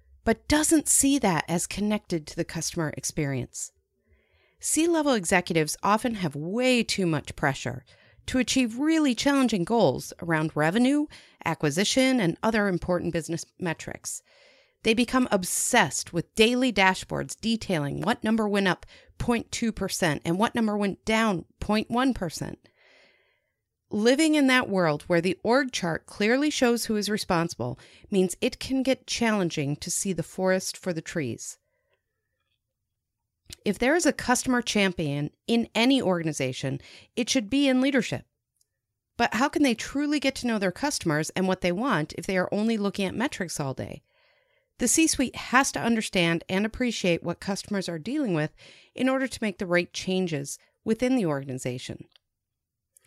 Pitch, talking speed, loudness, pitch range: 195 Hz, 155 wpm, -26 LUFS, 165-245 Hz